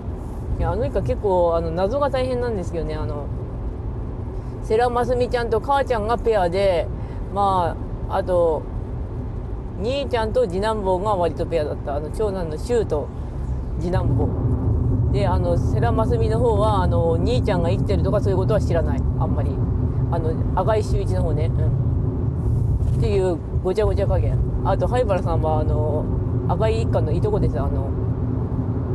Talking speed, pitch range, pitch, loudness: 305 characters per minute, 110-130 Hz, 120 Hz, -22 LUFS